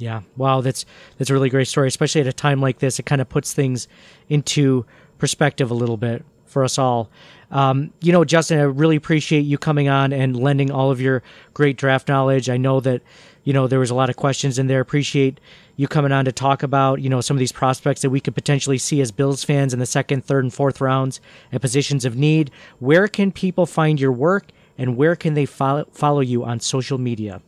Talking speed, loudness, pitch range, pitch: 230 wpm, -19 LUFS, 130-145 Hz, 135 Hz